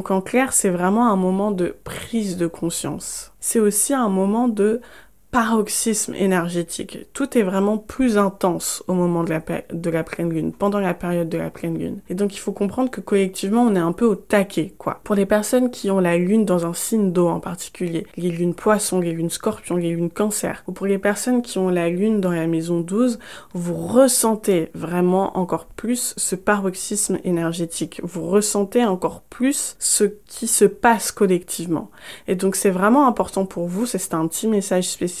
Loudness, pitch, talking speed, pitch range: -20 LUFS, 195 Hz, 200 wpm, 175-215 Hz